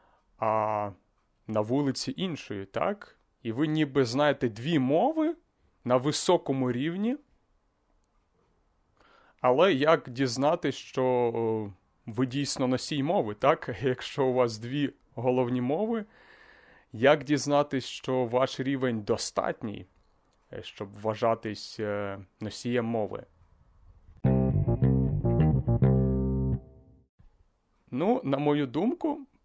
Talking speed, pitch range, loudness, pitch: 90 wpm, 105-145 Hz, -28 LUFS, 125 Hz